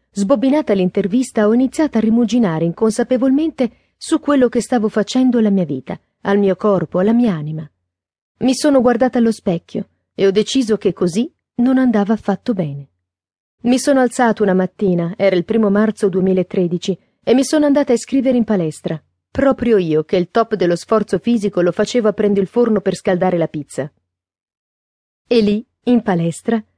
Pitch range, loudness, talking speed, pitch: 180-240 Hz, -16 LUFS, 170 wpm, 210 Hz